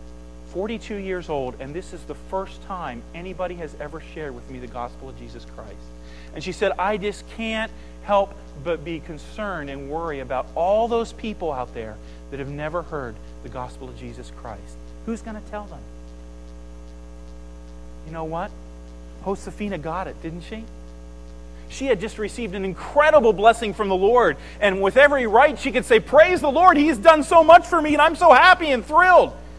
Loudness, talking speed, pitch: -19 LUFS, 185 wpm, 170 Hz